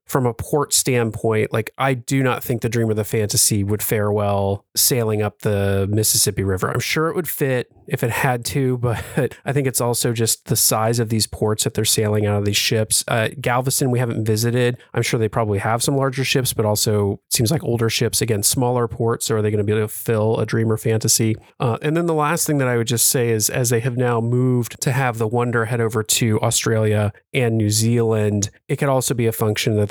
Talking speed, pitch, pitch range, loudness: 235 wpm, 115 Hz, 110-125 Hz, -19 LUFS